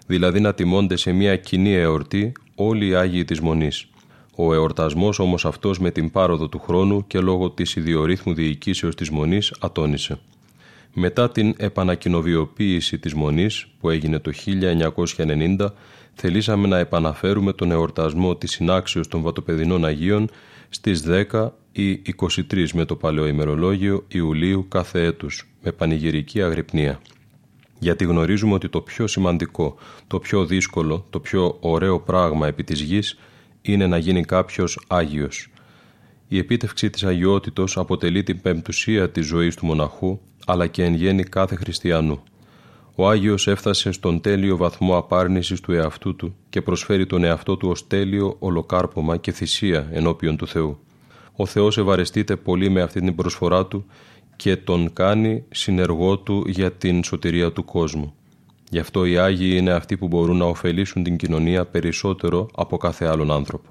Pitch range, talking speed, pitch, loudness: 85-100 Hz, 150 wpm, 90 Hz, -21 LUFS